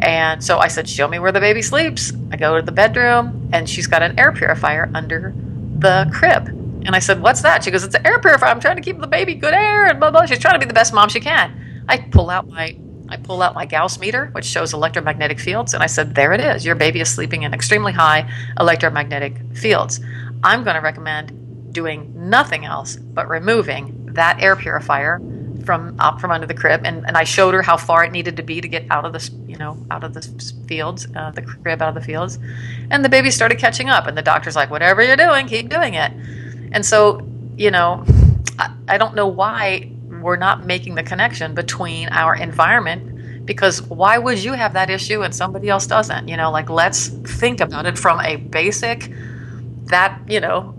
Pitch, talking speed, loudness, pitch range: 150 Hz, 220 wpm, -16 LUFS, 120-170 Hz